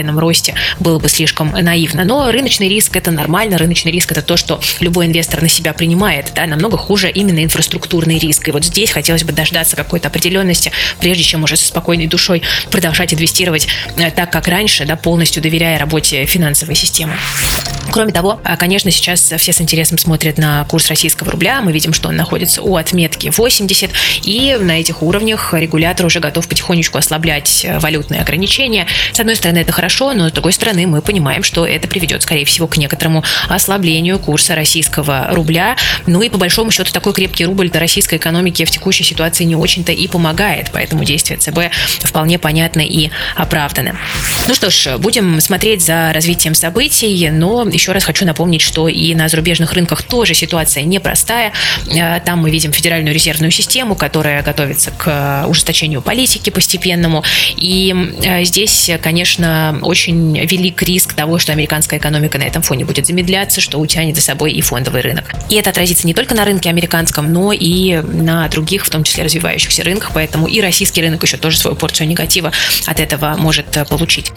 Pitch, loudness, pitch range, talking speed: 165 Hz, -11 LUFS, 155-180 Hz, 175 wpm